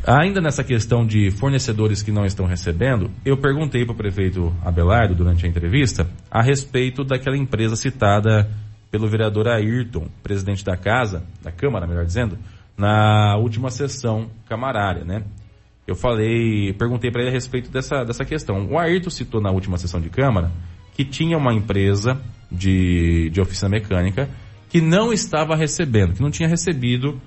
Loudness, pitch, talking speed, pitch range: -20 LUFS, 110 Hz, 160 wpm, 100-130 Hz